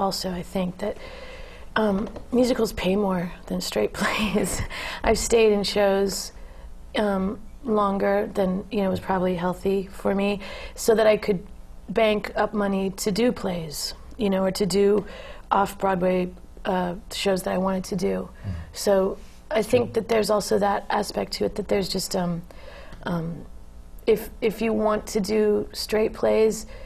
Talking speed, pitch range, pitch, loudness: 160 wpm, 185-215 Hz, 200 Hz, -24 LUFS